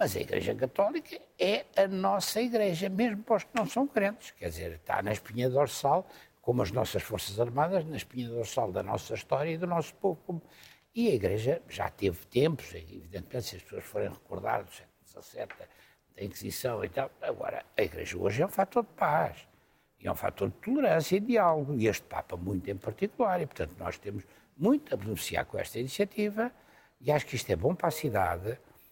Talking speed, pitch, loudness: 205 wpm, 180 Hz, -31 LUFS